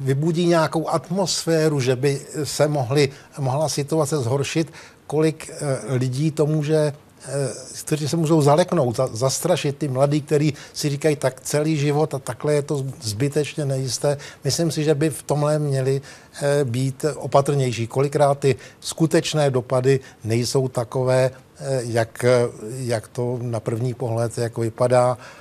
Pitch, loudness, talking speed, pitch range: 140 Hz, -22 LUFS, 130 wpm, 130-150 Hz